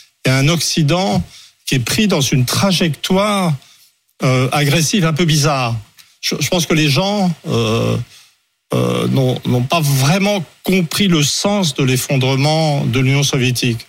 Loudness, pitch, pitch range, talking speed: -15 LUFS, 150 Hz, 130-175 Hz, 145 wpm